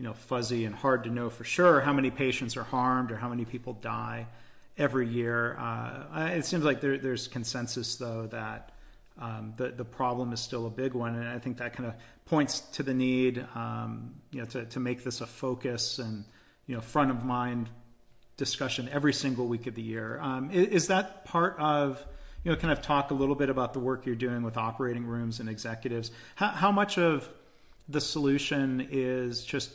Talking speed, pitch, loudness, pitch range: 210 wpm, 125 Hz, -31 LUFS, 120-140 Hz